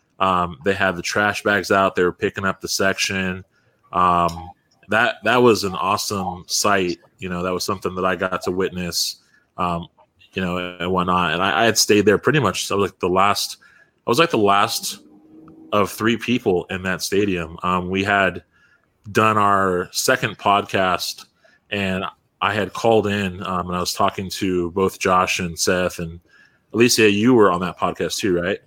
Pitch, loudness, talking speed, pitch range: 95 Hz, -19 LUFS, 190 wpm, 90-100 Hz